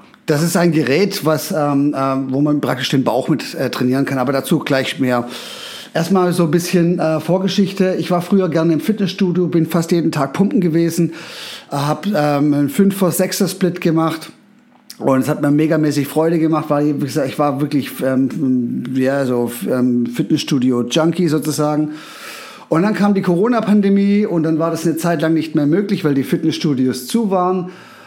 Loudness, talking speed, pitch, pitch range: -16 LUFS, 185 wpm, 160 Hz, 145-180 Hz